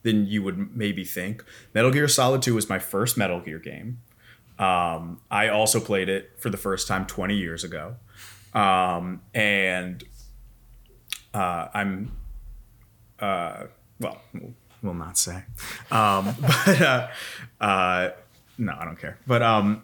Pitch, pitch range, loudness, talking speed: 105 Hz, 95-120 Hz, -24 LUFS, 140 wpm